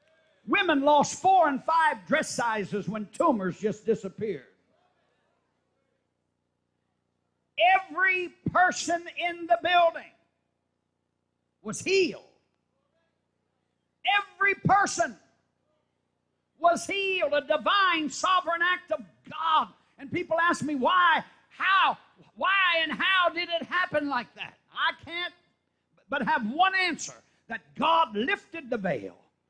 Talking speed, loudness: 110 wpm, -26 LUFS